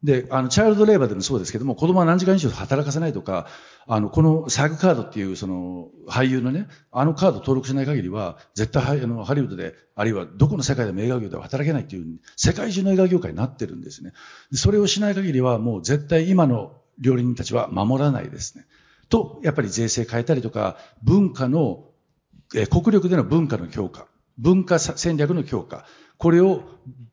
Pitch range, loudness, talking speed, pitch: 120-165 Hz, -21 LUFS, 410 characters per minute, 135 Hz